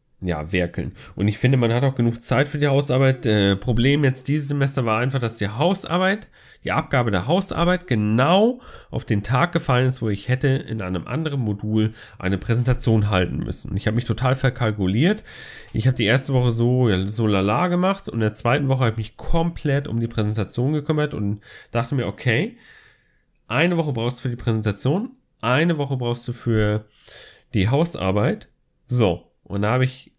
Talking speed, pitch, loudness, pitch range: 190 wpm, 125 Hz, -21 LUFS, 110-140 Hz